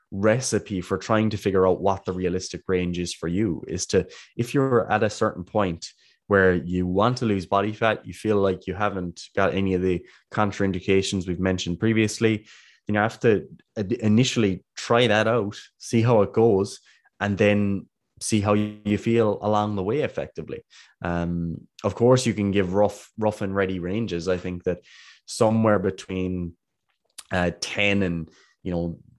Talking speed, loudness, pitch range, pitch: 175 wpm, -24 LUFS, 90-110 Hz, 100 Hz